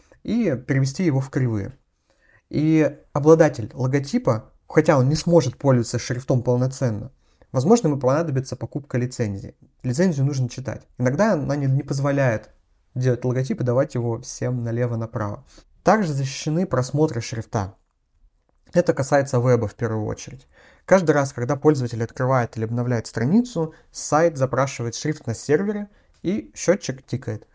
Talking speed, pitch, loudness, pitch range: 130 wpm, 130 Hz, -22 LUFS, 120-150 Hz